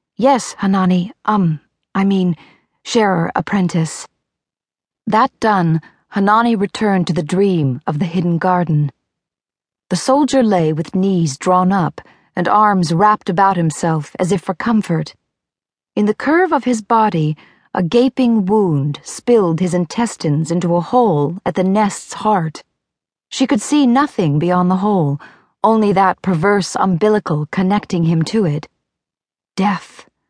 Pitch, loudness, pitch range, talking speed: 190 Hz, -16 LUFS, 170-215 Hz, 135 wpm